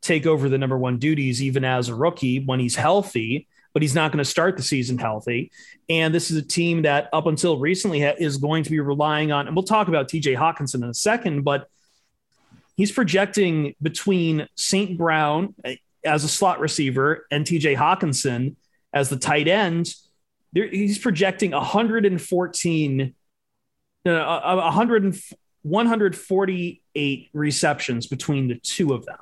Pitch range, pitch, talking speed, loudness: 140-185 Hz, 155 Hz, 155 wpm, -22 LUFS